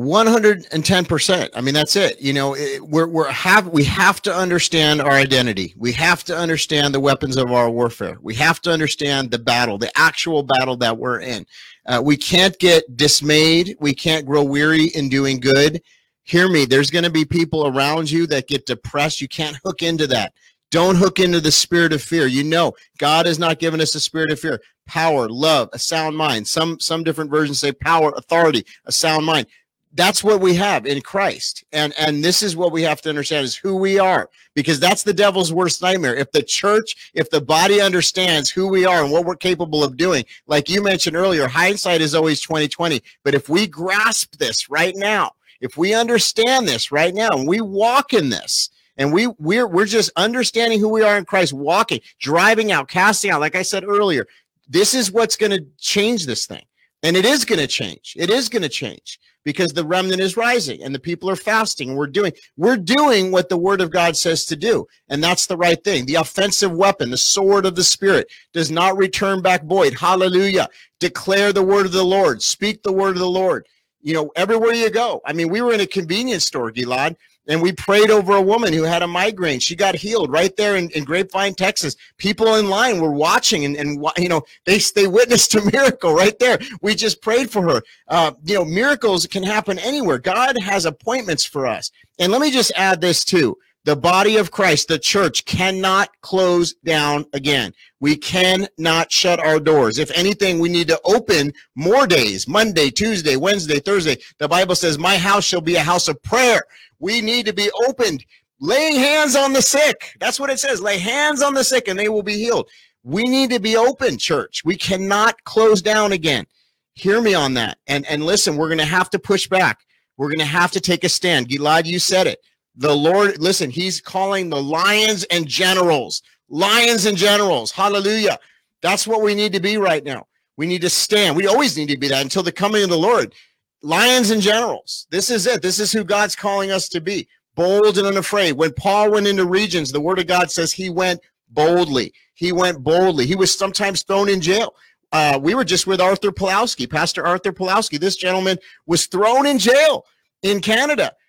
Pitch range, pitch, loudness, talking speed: 155-200 Hz, 180 Hz, -17 LUFS, 210 wpm